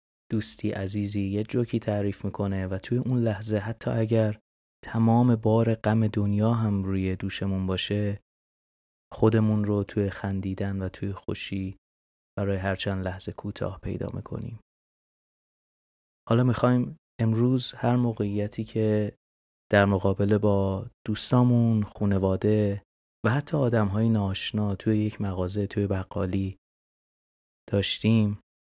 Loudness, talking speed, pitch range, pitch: -26 LUFS, 115 wpm, 95-110 Hz, 105 Hz